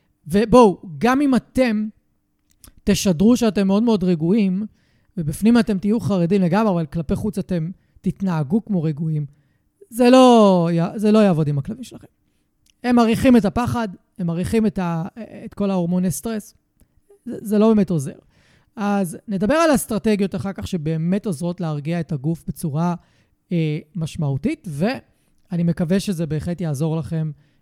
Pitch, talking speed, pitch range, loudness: 195 Hz, 140 wpm, 170-215 Hz, -19 LUFS